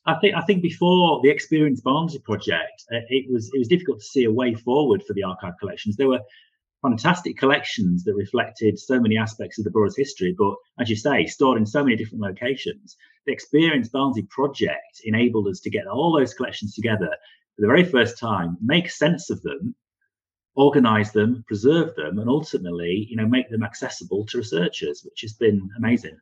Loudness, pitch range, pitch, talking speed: -22 LUFS, 110-165 Hz, 125 Hz, 190 wpm